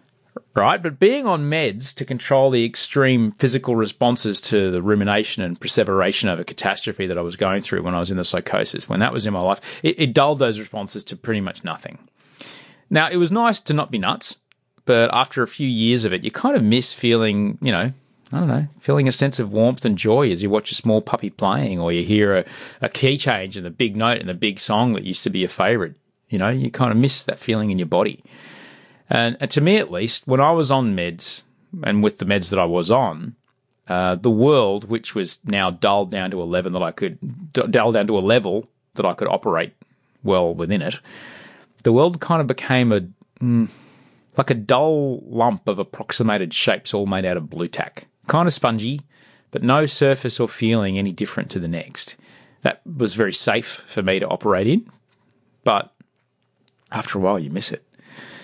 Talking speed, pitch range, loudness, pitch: 215 wpm, 100-135 Hz, -20 LUFS, 115 Hz